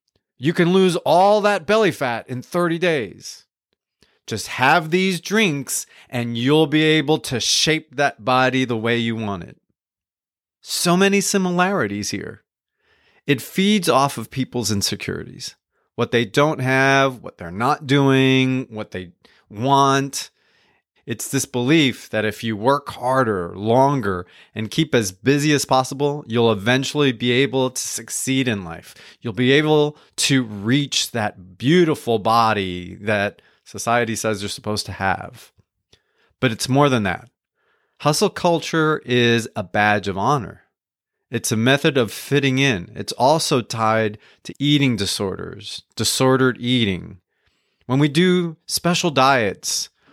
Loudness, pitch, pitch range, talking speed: -19 LUFS, 130 Hz, 110-150 Hz, 140 wpm